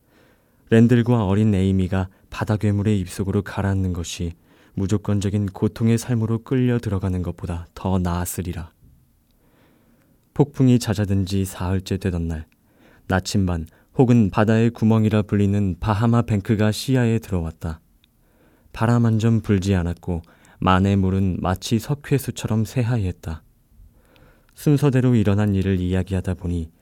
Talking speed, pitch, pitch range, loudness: 295 characters per minute, 100 Hz, 90-115 Hz, -21 LUFS